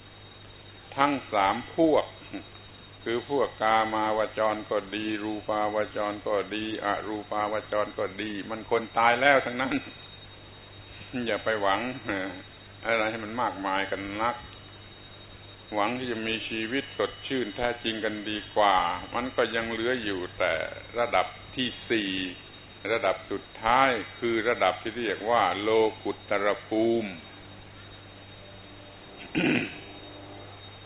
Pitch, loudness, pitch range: 105 Hz, -28 LUFS, 100-110 Hz